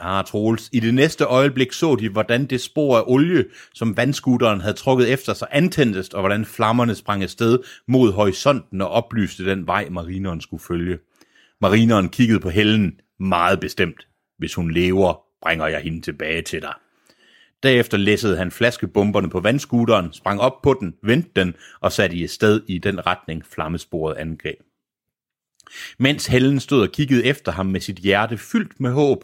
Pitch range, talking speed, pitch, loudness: 95-125 Hz, 170 wpm, 105 Hz, -19 LUFS